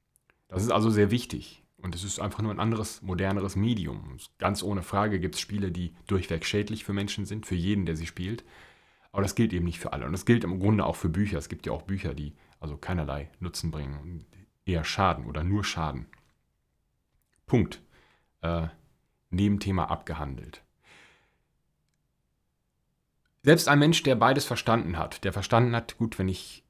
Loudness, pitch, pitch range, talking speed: -28 LUFS, 95 Hz, 85-105 Hz, 180 wpm